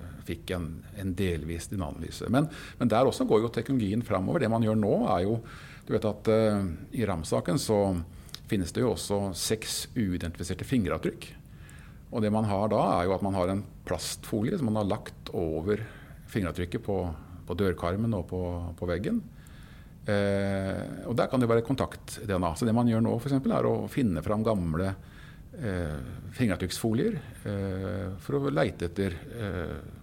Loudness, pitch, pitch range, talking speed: -29 LUFS, 100 Hz, 90-115 Hz, 155 wpm